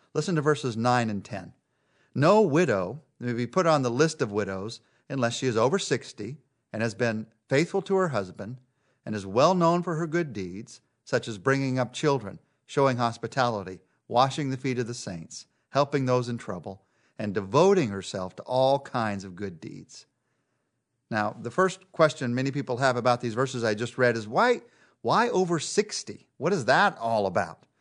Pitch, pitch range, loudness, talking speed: 125 Hz, 110-145 Hz, -26 LUFS, 185 wpm